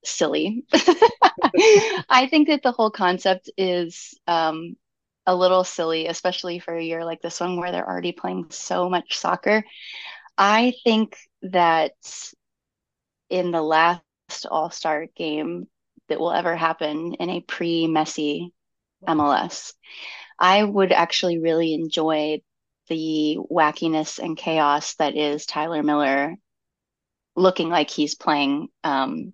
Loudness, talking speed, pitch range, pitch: -21 LUFS, 125 wpm, 155-185 Hz, 170 Hz